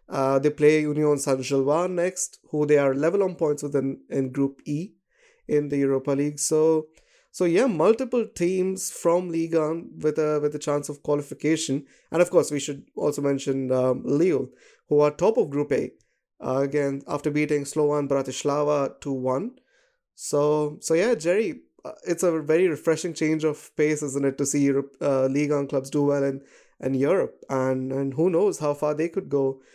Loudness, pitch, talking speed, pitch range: -24 LUFS, 150 Hz, 185 wpm, 140-160 Hz